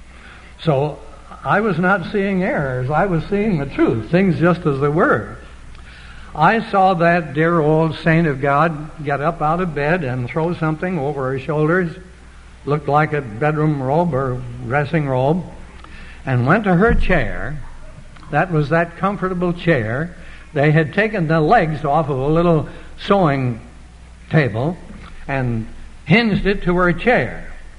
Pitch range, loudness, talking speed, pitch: 130-175 Hz, -18 LUFS, 150 wpm, 155 Hz